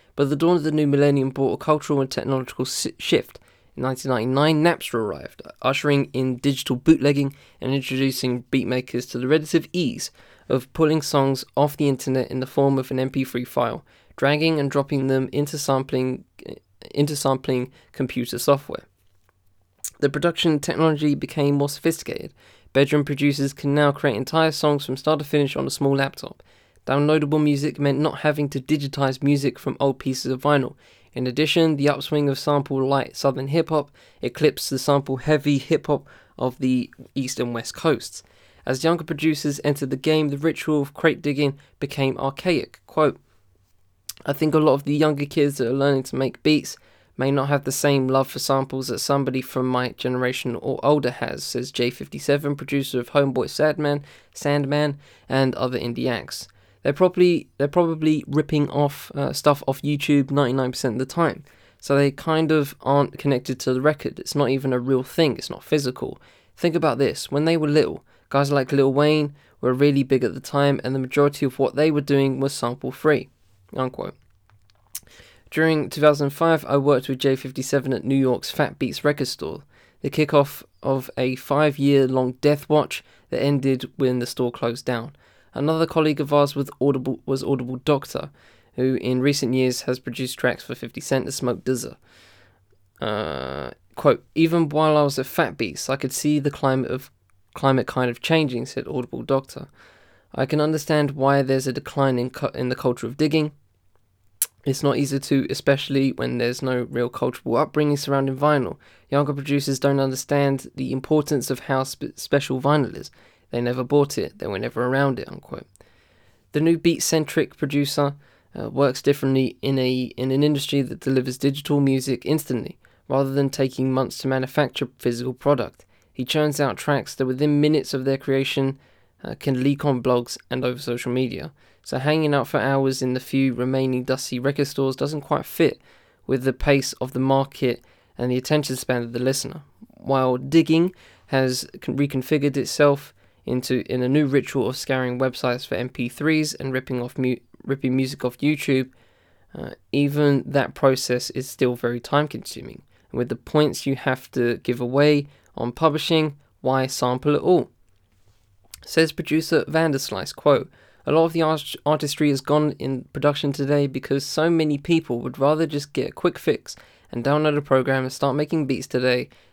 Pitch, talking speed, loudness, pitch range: 135 Hz, 175 wpm, -22 LUFS, 130-145 Hz